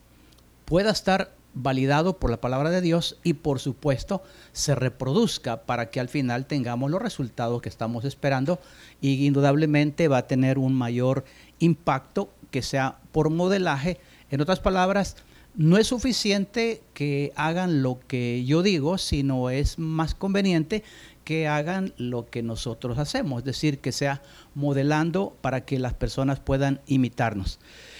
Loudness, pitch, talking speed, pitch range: -25 LUFS, 140 Hz, 145 wpm, 130-165 Hz